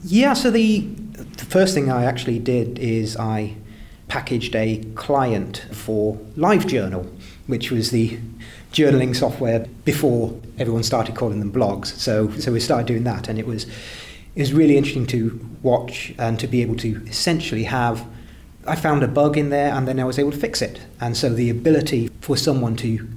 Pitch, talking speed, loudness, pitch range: 120 Hz, 180 wpm, -21 LUFS, 110-140 Hz